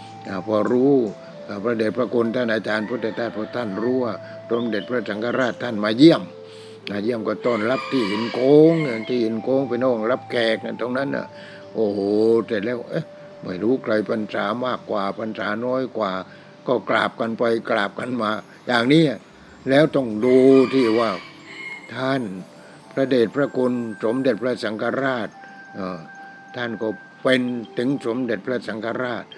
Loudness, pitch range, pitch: -21 LUFS, 110-130 Hz, 115 Hz